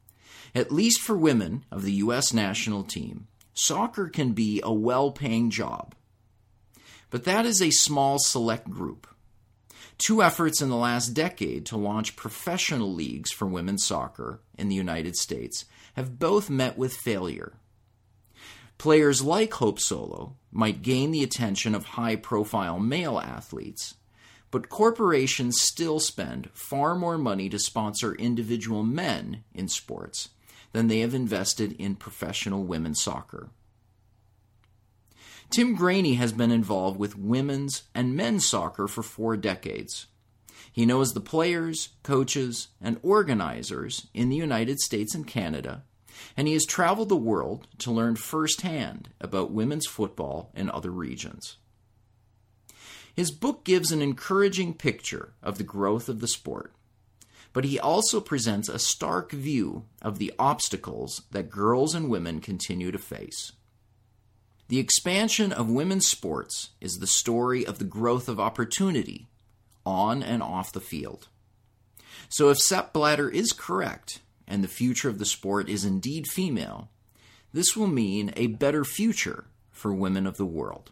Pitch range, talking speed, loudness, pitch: 105-140 Hz, 145 wpm, -26 LUFS, 115 Hz